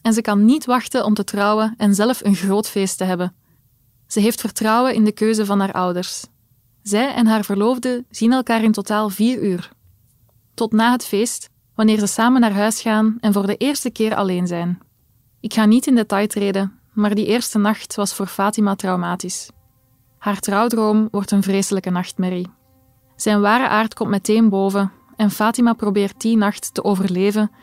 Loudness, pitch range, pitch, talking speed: -18 LUFS, 195-220 Hz, 210 Hz, 180 wpm